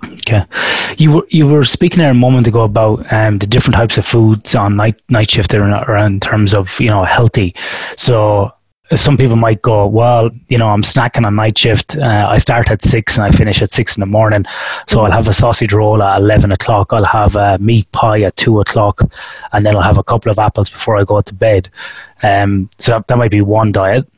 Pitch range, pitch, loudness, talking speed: 105-120 Hz, 110 Hz, -11 LUFS, 230 wpm